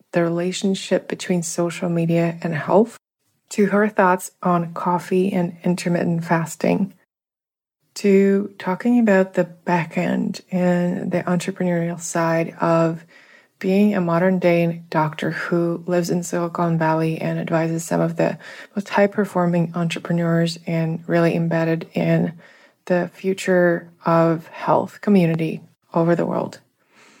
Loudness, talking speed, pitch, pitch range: -20 LUFS, 125 wpm, 175 Hz, 170-185 Hz